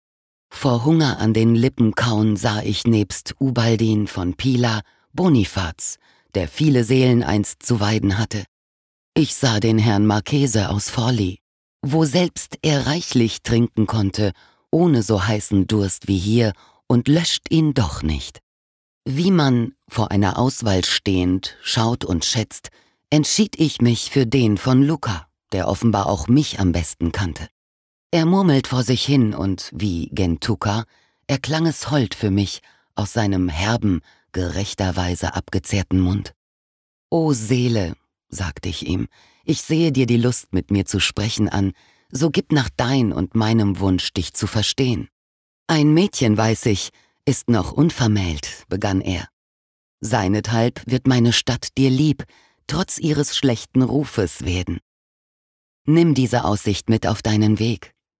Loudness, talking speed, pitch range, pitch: -19 LUFS, 140 wpm, 95-130 Hz, 110 Hz